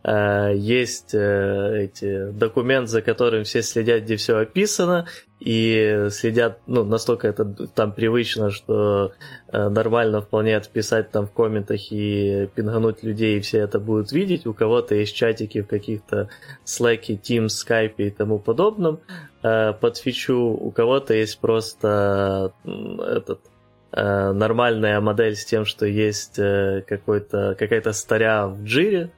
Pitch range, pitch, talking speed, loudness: 105-115 Hz, 110 Hz, 125 wpm, -21 LUFS